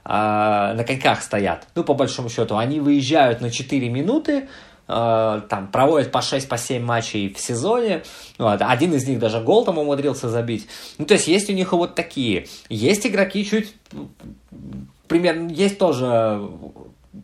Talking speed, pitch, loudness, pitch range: 150 wpm, 130 Hz, -20 LUFS, 110-170 Hz